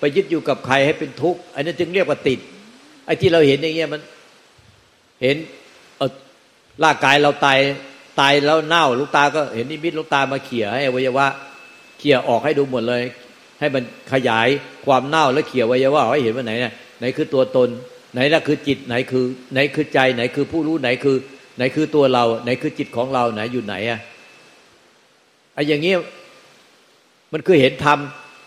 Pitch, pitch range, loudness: 140 Hz, 125-150 Hz, -18 LUFS